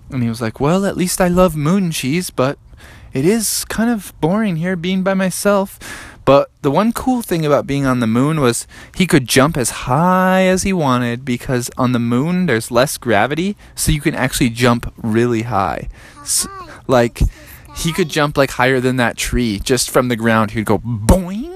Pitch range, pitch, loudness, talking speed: 120-185 Hz, 140 Hz, -16 LUFS, 200 wpm